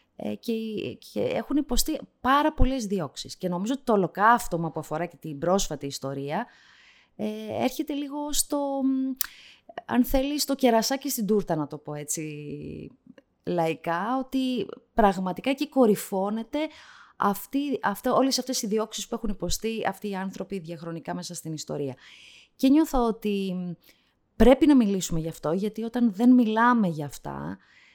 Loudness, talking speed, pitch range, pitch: -26 LUFS, 145 wpm, 170-260 Hz, 215 Hz